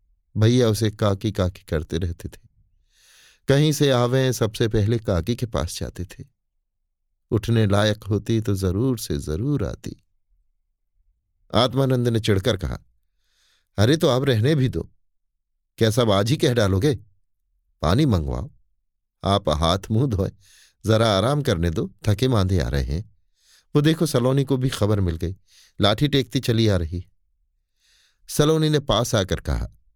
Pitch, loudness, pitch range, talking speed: 105 Hz, -22 LUFS, 90-125 Hz, 145 wpm